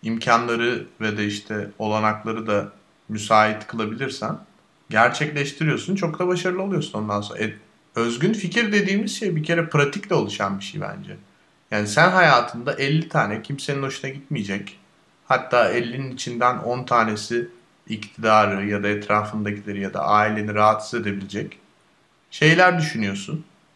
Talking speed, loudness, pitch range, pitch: 130 wpm, -21 LUFS, 105-150 Hz, 115 Hz